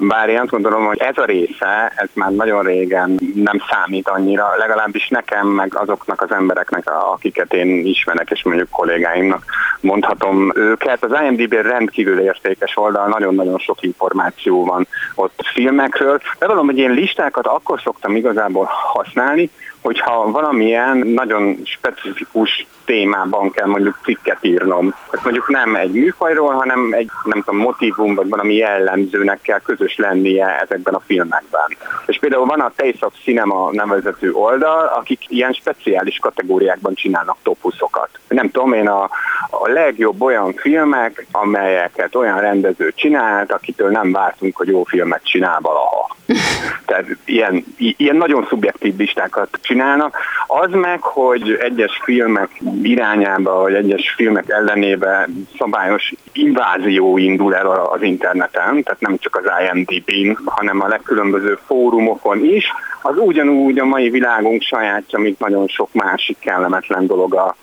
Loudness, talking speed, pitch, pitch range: -15 LUFS, 140 wpm, 105 Hz, 95-135 Hz